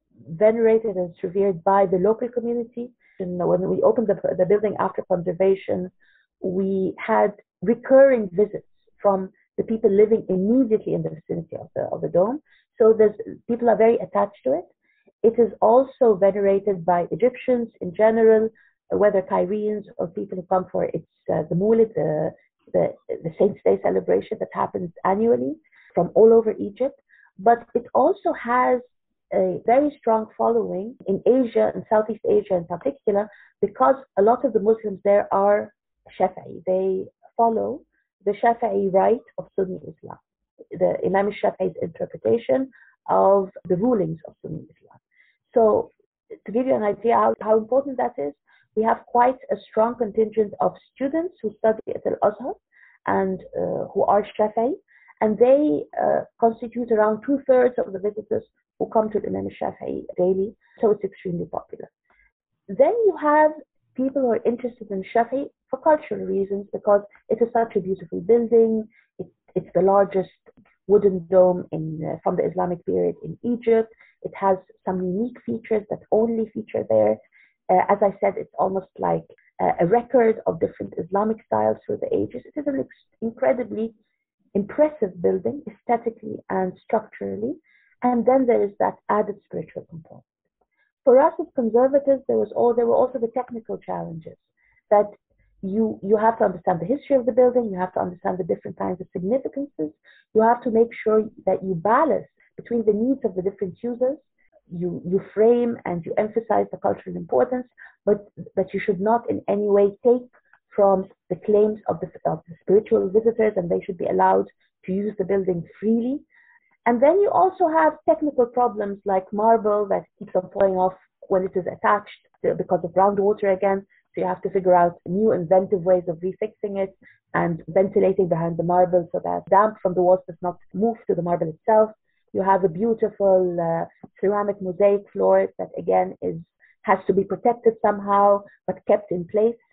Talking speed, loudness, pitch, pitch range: 170 wpm, -22 LUFS, 210 Hz, 190-240 Hz